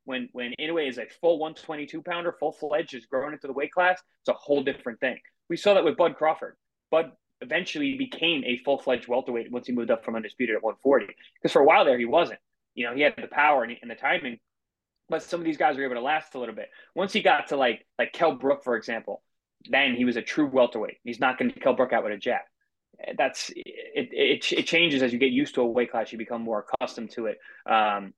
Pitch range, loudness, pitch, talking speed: 125-170 Hz, -26 LUFS, 150 Hz, 255 wpm